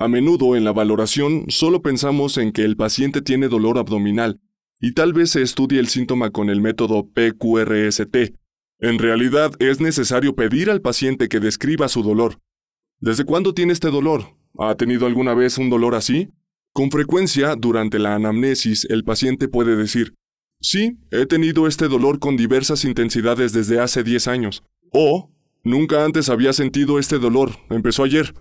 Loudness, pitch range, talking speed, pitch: -18 LUFS, 115-145 Hz, 165 wpm, 125 Hz